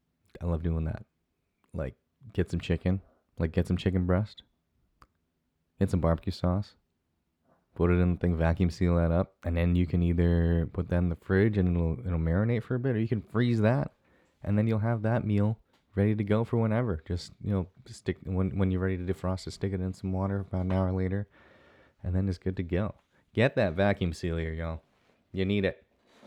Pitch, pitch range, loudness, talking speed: 95 Hz, 85-100 Hz, -29 LUFS, 215 wpm